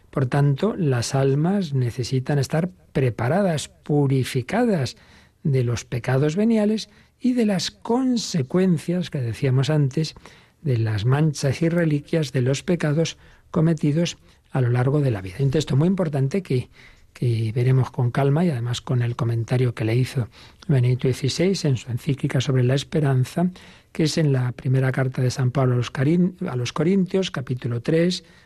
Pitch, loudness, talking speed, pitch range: 140 Hz, -22 LUFS, 160 wpm, 125-165 Hz